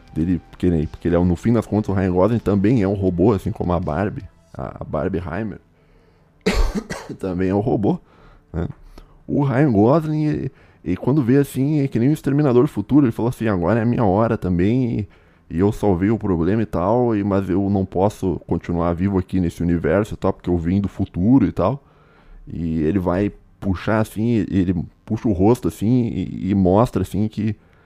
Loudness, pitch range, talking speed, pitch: -20 LUFS, 90-115 Hz, 195 wpm, 100 Hz